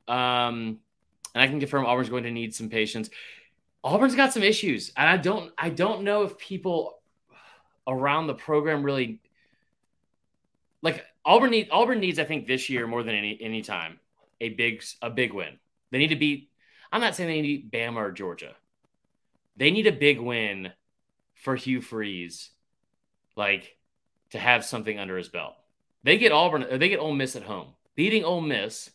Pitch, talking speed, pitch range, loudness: 130 Hz, 175 wpm, 115-165 Hz, -25 LUFS